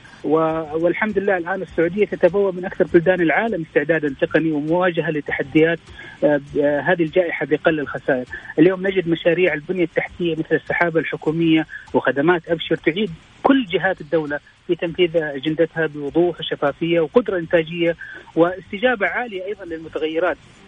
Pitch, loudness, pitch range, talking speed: 170 Hz, -20 LUFS, 160-185 Hz, 120 wpm